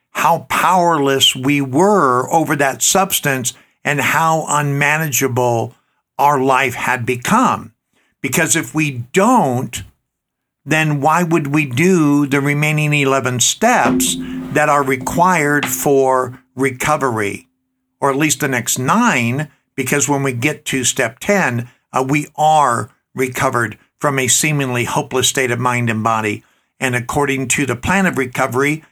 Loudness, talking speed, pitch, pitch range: -15 LUFS, 135 wpm, 135 Hz, 125-150 Hz